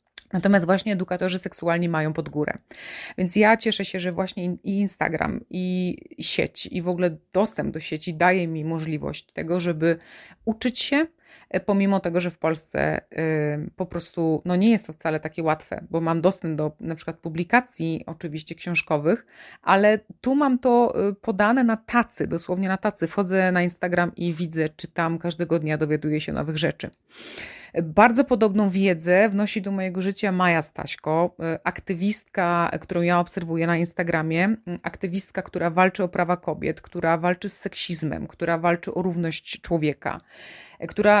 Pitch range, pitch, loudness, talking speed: 165-200 Hz, 180 Hz, -23 LUFS, 155 wpm